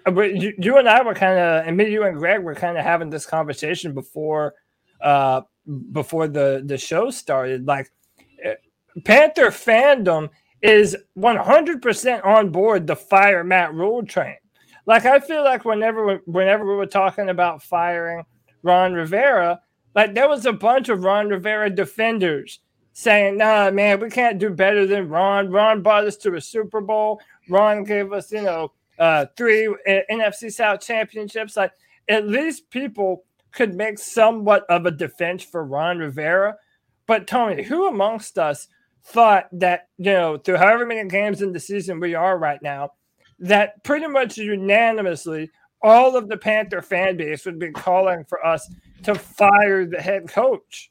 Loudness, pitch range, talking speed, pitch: -19 LUFS, 175-220 Hz, 165 wpm, 200 Hz